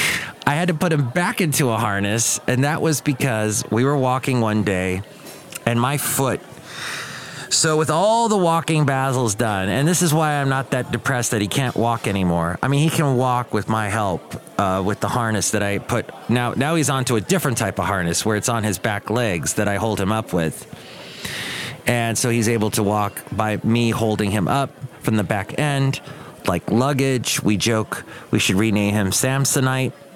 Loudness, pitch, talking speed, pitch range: -20 LUFS, 120 Hz, 200 wpm, 105-140 Hz